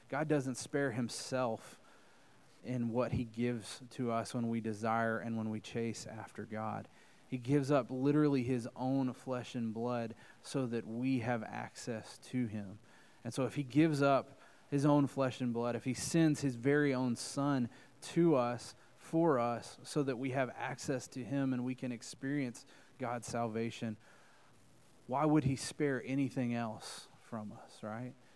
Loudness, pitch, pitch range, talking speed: -36 LUFS, 125 Hz, 115-140 Hz, 165 wpm